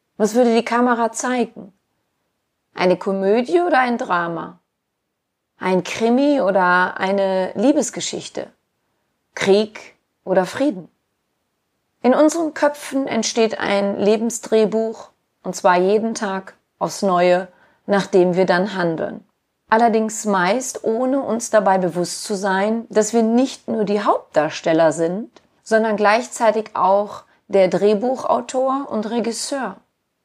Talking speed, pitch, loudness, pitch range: 110 wpm, 215 Hz, -18 LUFS, 190-240 Hz